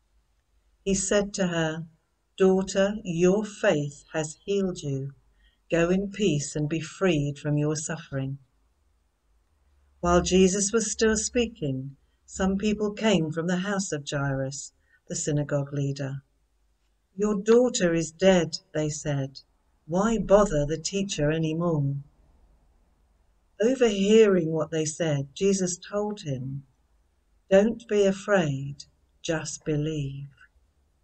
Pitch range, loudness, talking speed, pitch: 135-195 Hz, -26 LUFS, 115 wpm, 155 Hz